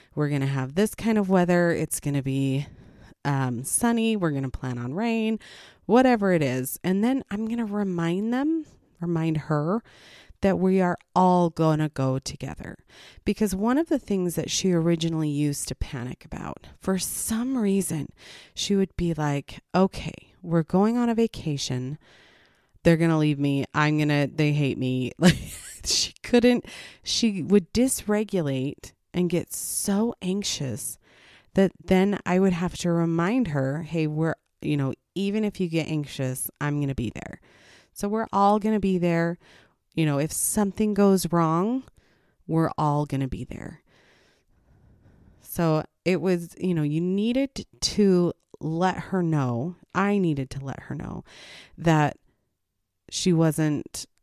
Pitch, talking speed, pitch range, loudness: 170 Hz, 160 wpm, 145-200 Hz, -25 LUFS